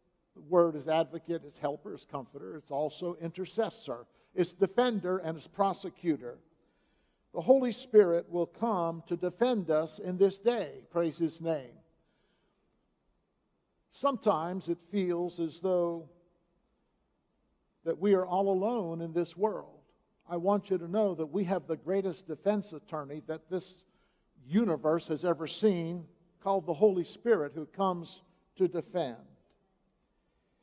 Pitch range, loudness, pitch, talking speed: 165-195 Hz, -32 LUFS, 175 Hz, 135 wpm